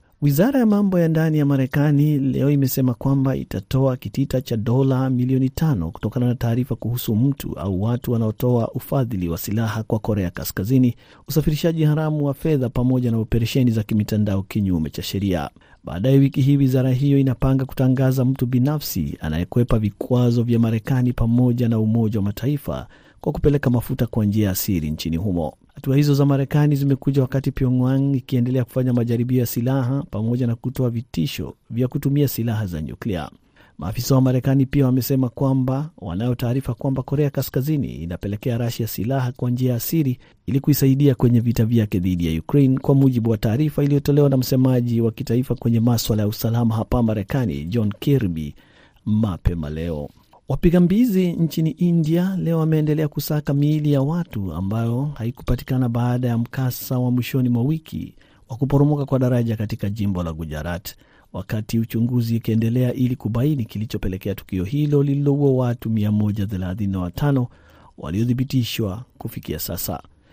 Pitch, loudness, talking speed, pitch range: 125 Hz, -21 LUFS, 150 wpm, 110-135 Hz